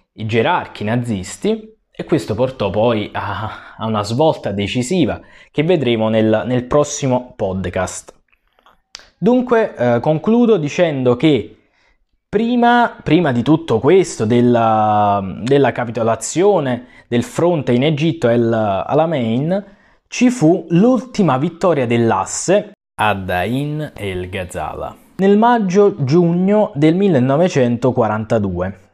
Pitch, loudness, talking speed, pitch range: 130 Hz, -16 LUFS, 100 wpm, 115-175 Hz